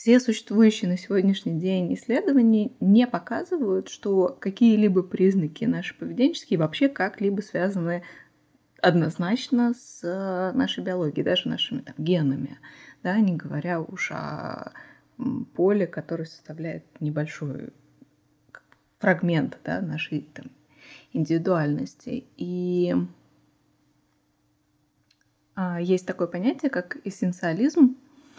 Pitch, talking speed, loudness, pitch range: 185 Hz, 95 wpm, -25 LUFS, 170-235 Hz